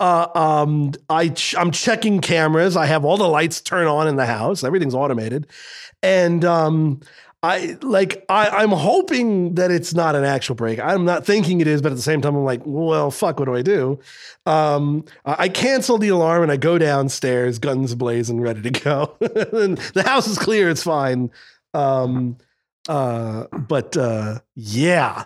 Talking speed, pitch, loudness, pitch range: 180 wpm, 155 Hz, -19 LUFS, 135-180 Hz